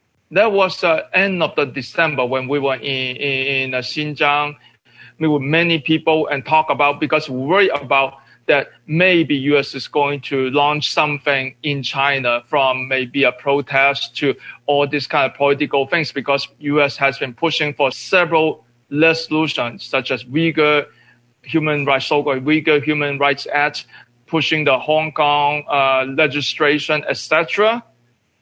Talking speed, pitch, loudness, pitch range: 155 wpm, 145 Hz, -17 LUFS, 135-155 Hz